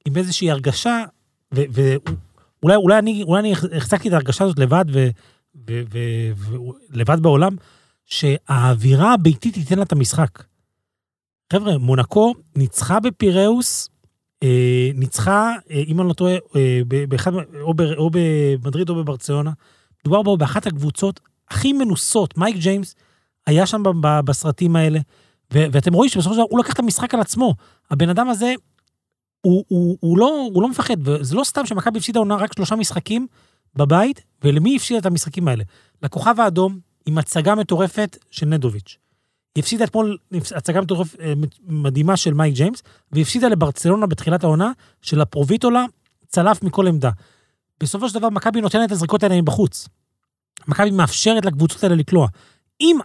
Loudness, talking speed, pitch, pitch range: -18 LUFS, 145 wpm, 170 Hz, 145-205 Hz